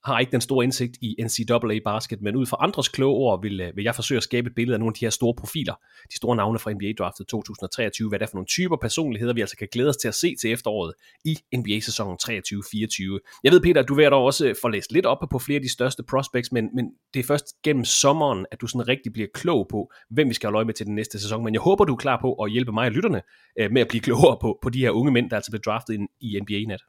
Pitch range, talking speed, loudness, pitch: 110-130 Hz, 285 wpm, -23 LUFS, 120 Hz